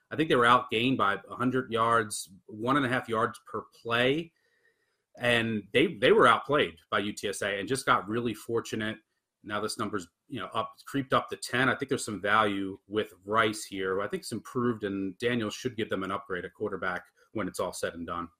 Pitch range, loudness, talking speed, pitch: 105-130 Hz, -29 LUFS, 210 wpm, 115 Hz